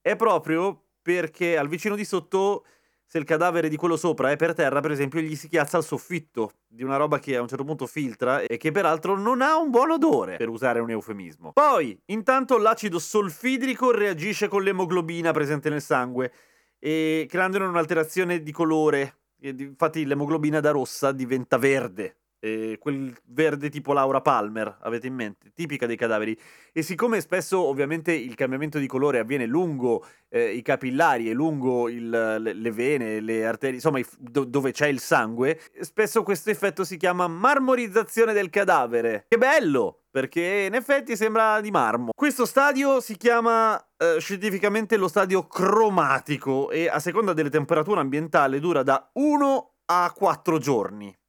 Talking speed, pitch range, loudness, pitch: 165 wpm, 135-200 Hz, -24 LUFS, 160 Hz